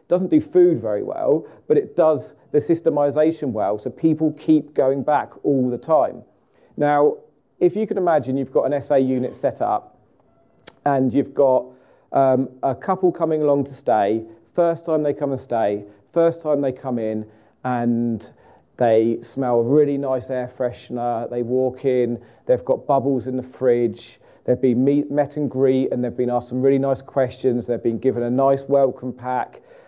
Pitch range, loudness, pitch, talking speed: 125-150 Hz, -20 LUFS, 135 Hz, 180 wpm